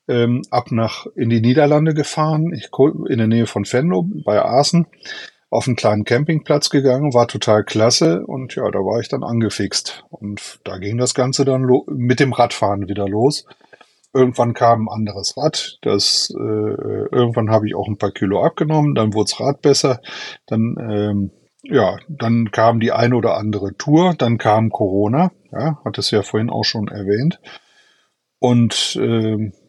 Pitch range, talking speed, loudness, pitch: 105-140 Hz, 170 wpm, -17 LUFS, 115 Hz